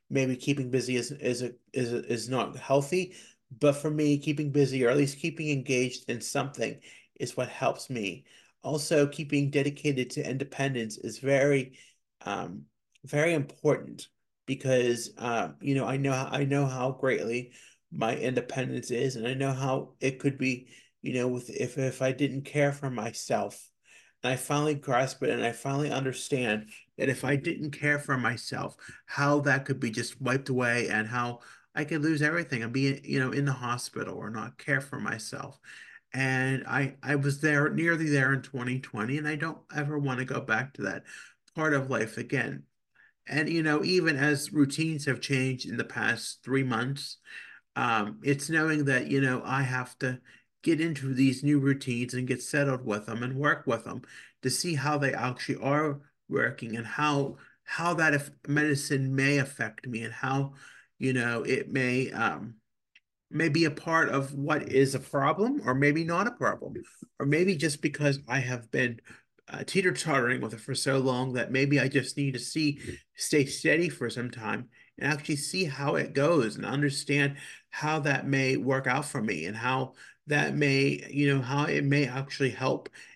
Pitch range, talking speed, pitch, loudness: 125-145 Hz, 185 wpm, 135 Hz, -29 LUFS